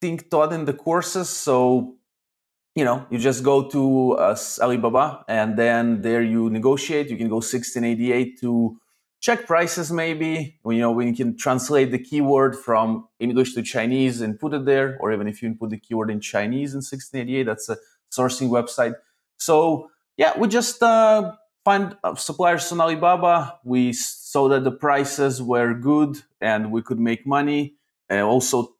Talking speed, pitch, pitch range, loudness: 170 wpm, 130 Hz, 115-155 Hz, -21 LUFS